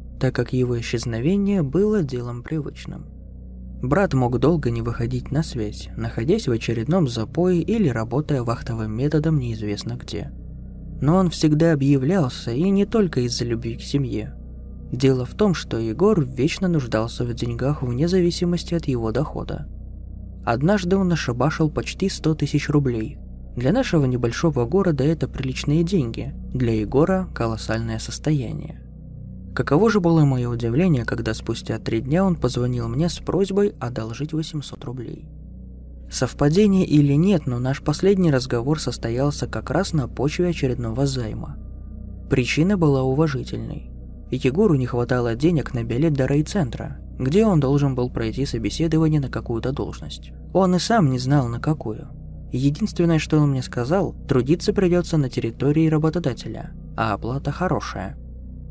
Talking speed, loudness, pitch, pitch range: 140 wpm, -22 LUFS, 135 Hz, 115-160 Hz